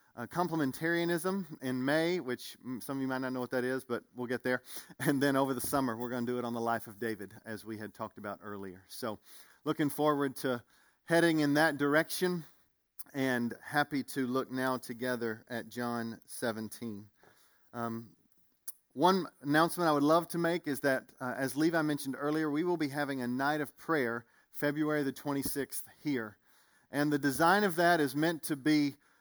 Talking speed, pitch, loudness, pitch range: 190 wpm, 135 Hz, -33 LUFS, 120-155 Hz